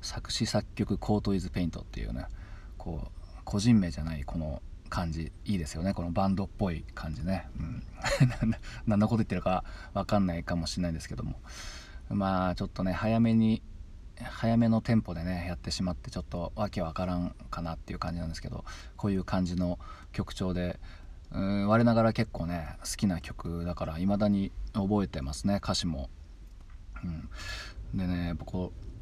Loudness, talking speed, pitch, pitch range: -31 LUFS, 335 characters per minute, 90 Hz, 85-100 Hz